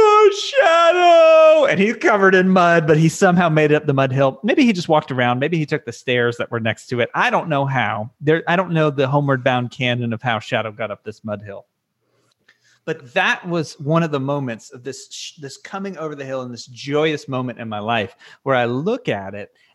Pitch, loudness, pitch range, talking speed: 145 Hz, -17 LUFS, 125-175 Hz, 230 wpm